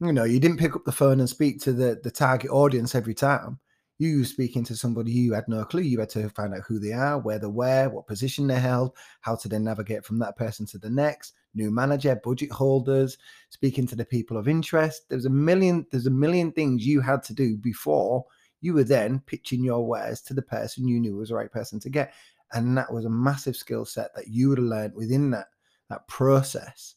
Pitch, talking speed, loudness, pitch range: 130 Hz, 235 wpm, -25 LUFS, 115-140 Hz